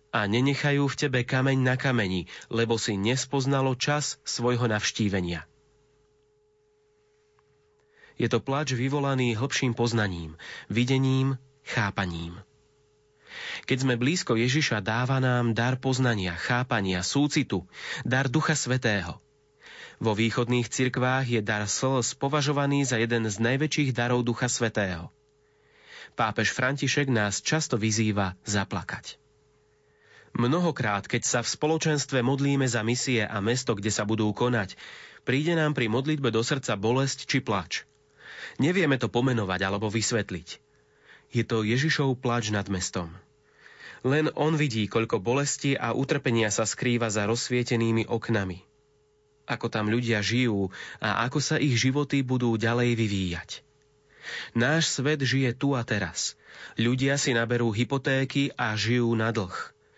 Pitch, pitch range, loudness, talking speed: 125 Hz, 110-140 Hz, -26 LUFS, 125 wpm